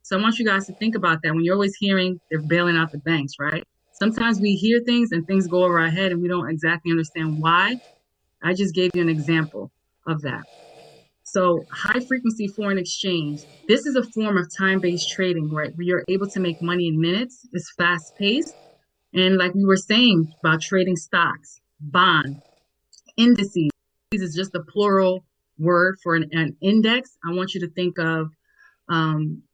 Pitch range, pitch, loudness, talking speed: 165-200 Hz, 180 Hz, -21 LUFS, 190 wpm